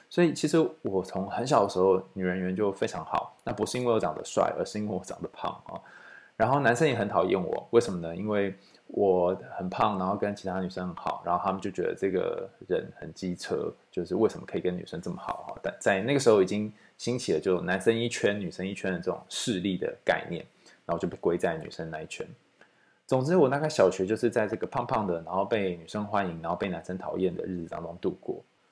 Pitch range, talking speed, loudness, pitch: 90-115 Hz, 345 characters per minute, -29 LUFS, 100 Hz